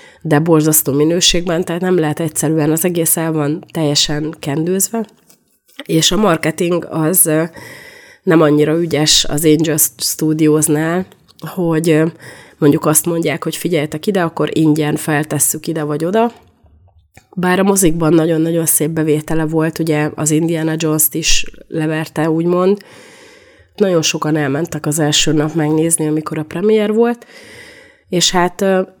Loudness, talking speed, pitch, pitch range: -14 LUFS, 130 wpm, 160 Hz, 155-175 Hz